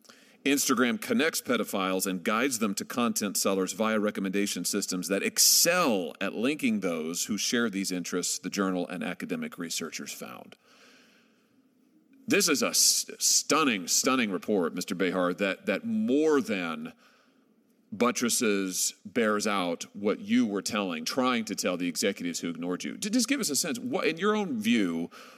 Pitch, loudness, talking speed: 225 Hz, -27 LUFS, 155 wpm